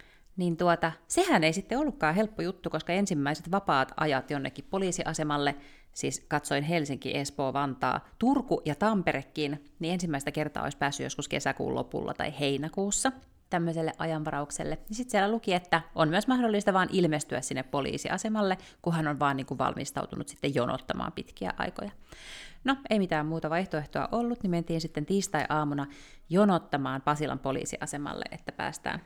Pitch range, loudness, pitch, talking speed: 145-195 Hz, -30 LUFS, 165 Hz, 145 wpm